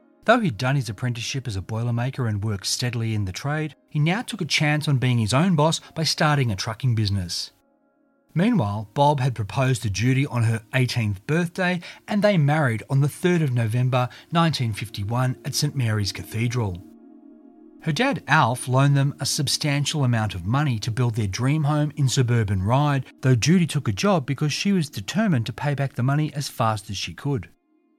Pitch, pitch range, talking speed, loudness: 135 Hz, 115-155 Hz, 190 wpm, -23 LUFS